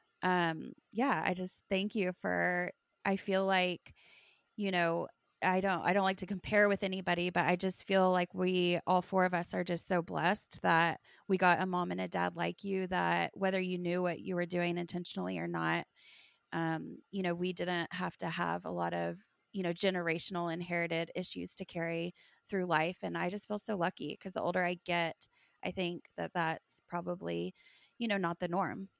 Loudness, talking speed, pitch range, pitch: -34 LUFS, 200 wpm, 170-190 Hz, 180 Hz